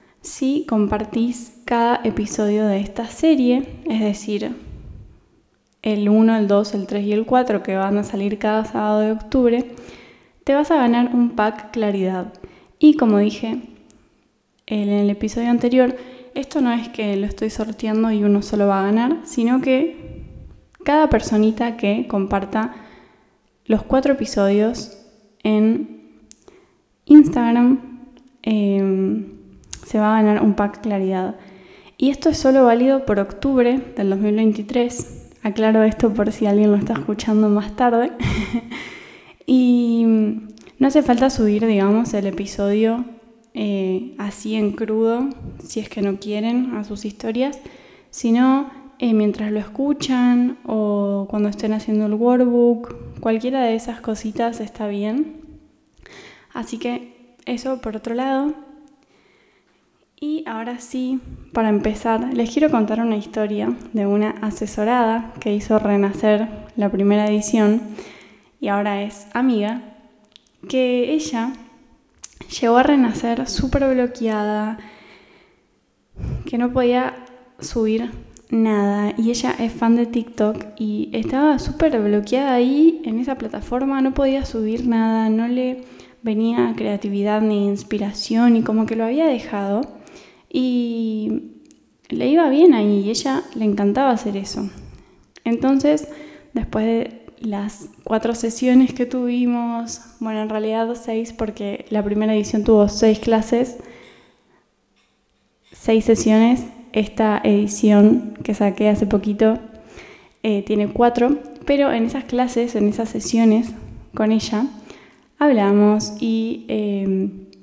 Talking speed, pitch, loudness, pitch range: 130 wpm, 225 Hz, -19 LUFS, 210-250 Hz